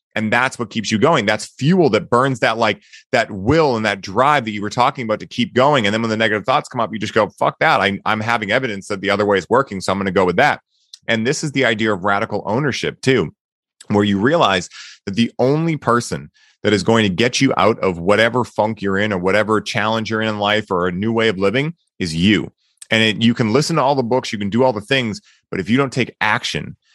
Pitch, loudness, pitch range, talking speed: 110 Hz, -17 LUFS, 105-120 Hz, 265 wpm